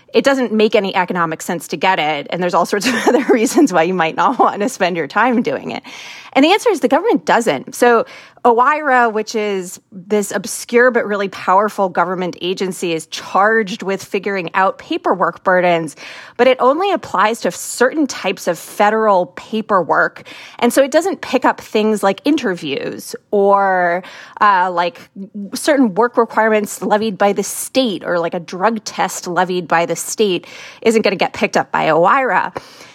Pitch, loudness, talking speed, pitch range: 210 Hz, -15 LUFS, 180 wpm, 185-245 Hz